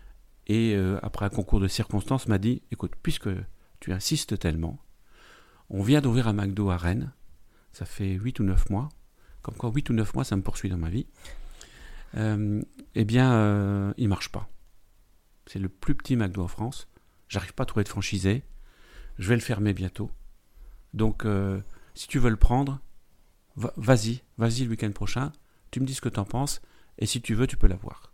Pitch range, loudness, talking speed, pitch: 100-125 Hz, -28 LUFS, 200 wpm, 105 Hz